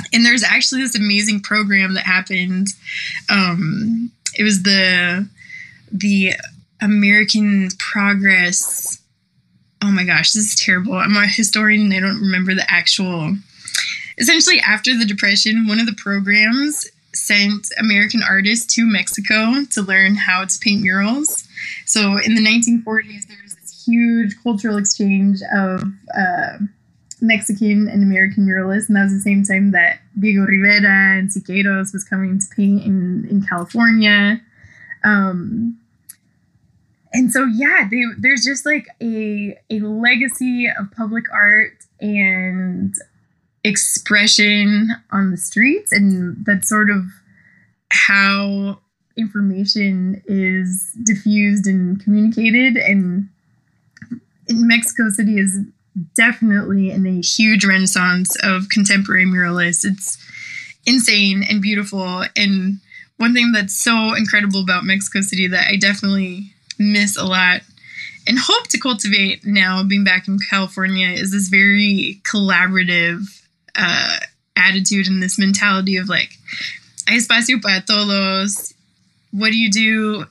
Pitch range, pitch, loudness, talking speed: 195-220 Hz, 205 Hz, -15 LUFS, 130 wpm